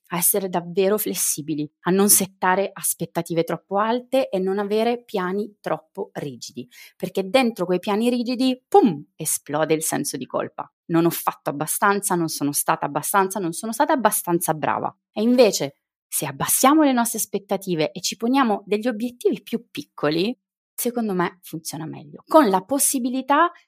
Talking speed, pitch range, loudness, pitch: 155 wpm, 165-235 Hz, -21 LUFS, 195 Hz